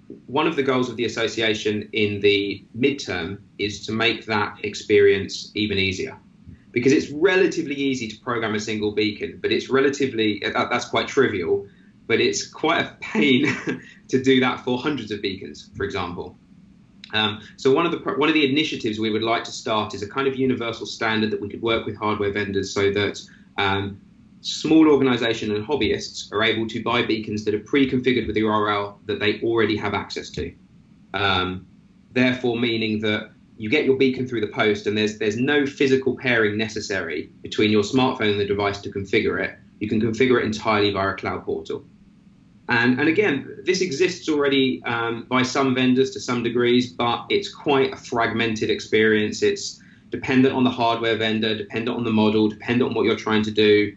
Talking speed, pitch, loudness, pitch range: 190 wpm, 115 Hz, -22 LUFS, 105-130 Hz